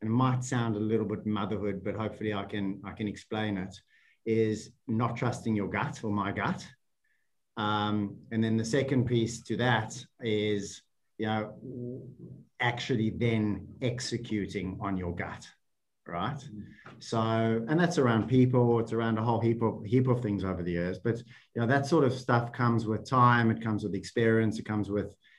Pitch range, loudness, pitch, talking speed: 105-120 Hz, -30 LUFS, 110 Hz, 180 wpm